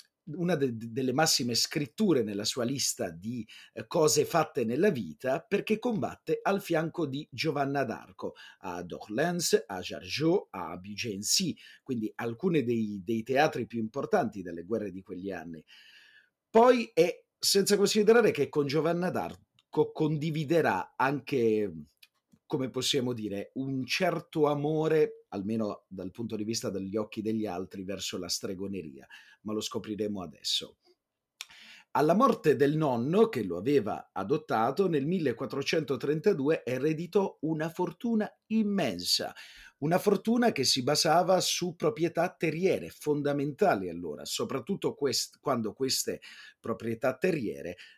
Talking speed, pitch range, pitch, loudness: 125 wpm, 110-170 Hz, 140 Hz, -29 LUFS